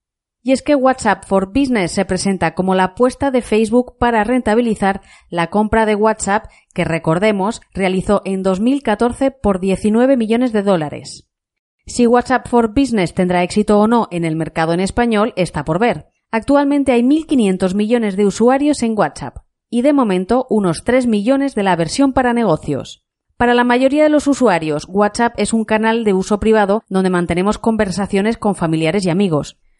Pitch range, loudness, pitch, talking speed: 190-245 Hz, -15 LUFS, 215 Hz, 170 wpm